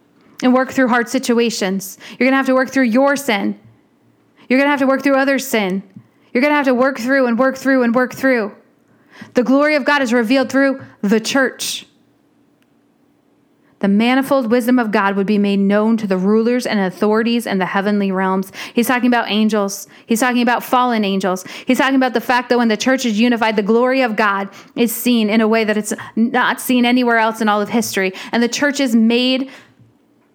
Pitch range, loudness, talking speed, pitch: 215-260 Hz, -16 LUFS, 210 wpm, 240 Hz